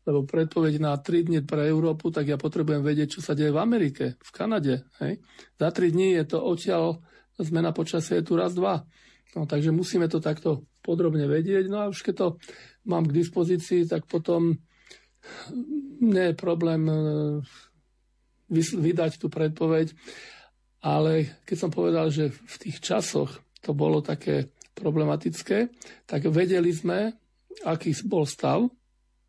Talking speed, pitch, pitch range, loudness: 150 wpm, 165 Hz, 150-175 Hz, -26 LUFS